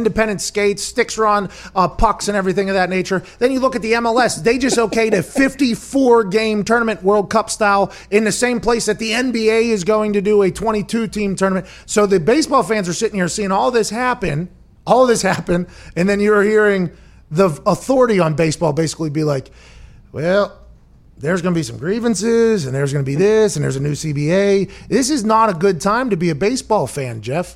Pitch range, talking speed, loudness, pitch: 180-225 Hz, 210 wpm, -16 LUFS, 205 Hz